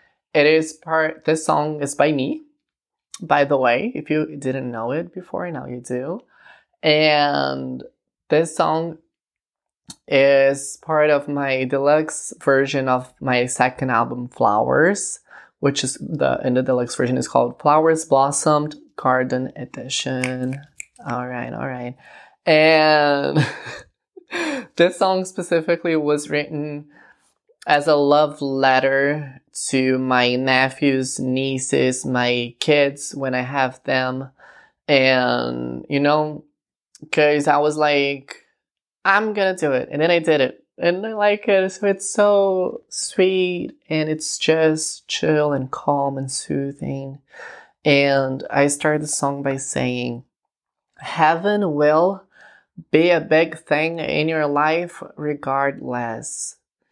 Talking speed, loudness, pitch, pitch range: 125 wpm, -19 LUFS, 145 Hz, 130-160 Hz